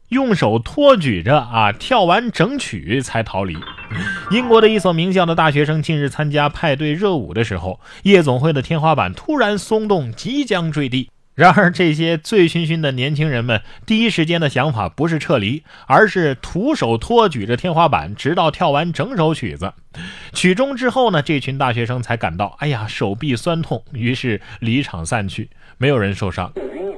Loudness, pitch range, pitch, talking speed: -17 LUFS, 115-180 Hz, 150 Hz, 270 characters per minute